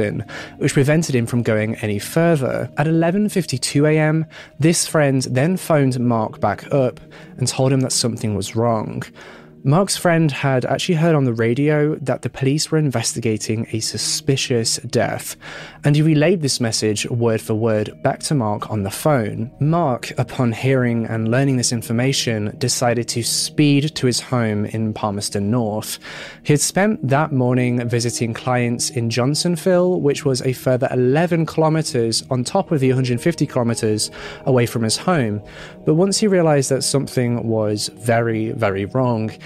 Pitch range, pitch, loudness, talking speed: 115-150 Hz, 125 Hz, -19 LUFS, 160 wpm